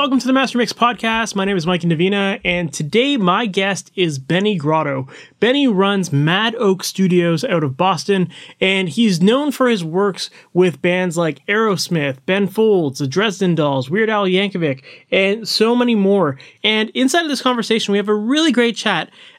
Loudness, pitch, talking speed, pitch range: -17 LUFS, 195 Hz, 185 wpm, 175-225 Hz